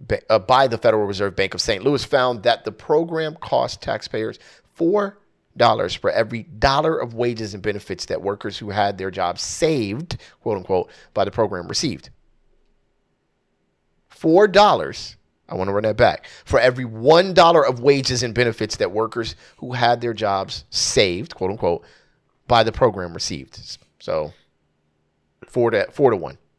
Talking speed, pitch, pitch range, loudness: 160 wpm, 115 Hz, 100-130 Hz, -20 LUFS